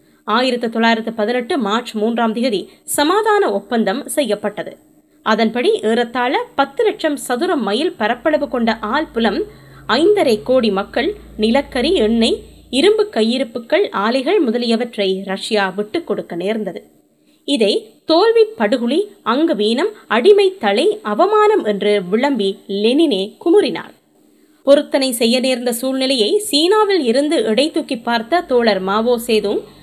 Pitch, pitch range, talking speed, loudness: 250 Hz, 220-330 Hz, 110 wpm, -16 LUFS